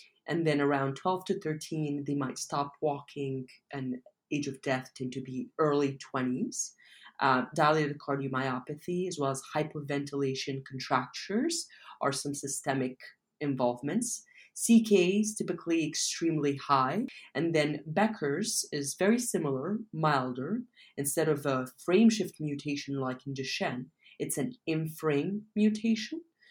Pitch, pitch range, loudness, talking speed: 150 Hz, 135-185 Hz, -31 LUFS, 125 wpm